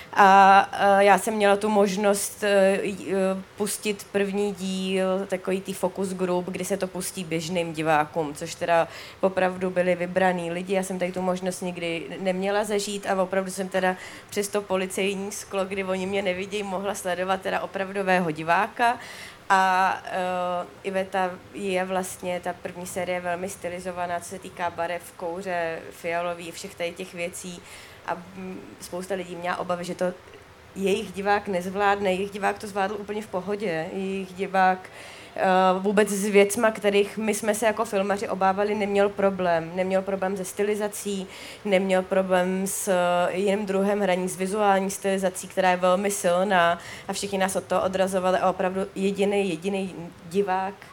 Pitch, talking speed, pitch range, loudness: 190 Hz, 150 wpm, 180-195 Hz, -25 LUFS